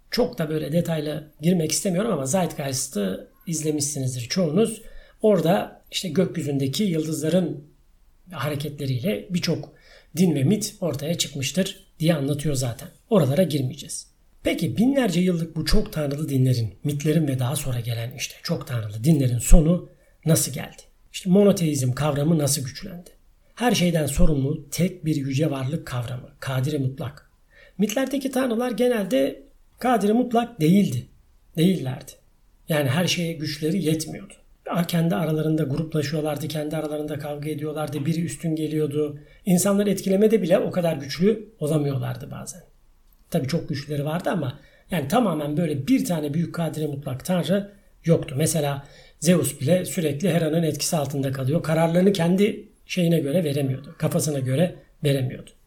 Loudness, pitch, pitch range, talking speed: -24 LUFS, 160 Hz, 145-180 Hz, 130 wpm